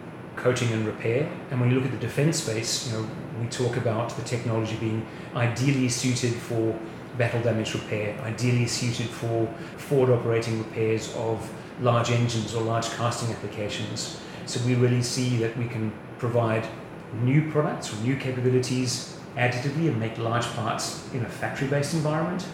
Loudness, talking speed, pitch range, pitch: -27 LUFS, 160 wpm, 115-130 Hz, 120 Hz